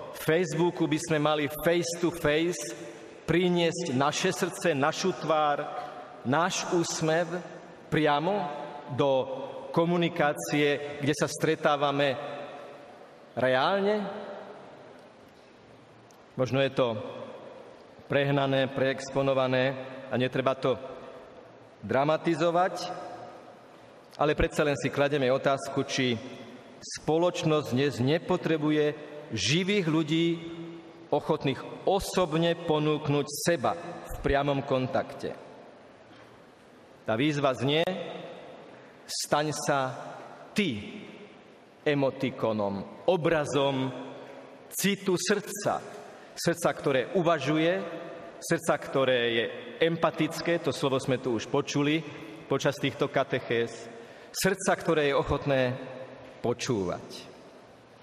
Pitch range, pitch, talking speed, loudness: 135-170 Hz, 150 Hz, 85 wpm, -28 LUFS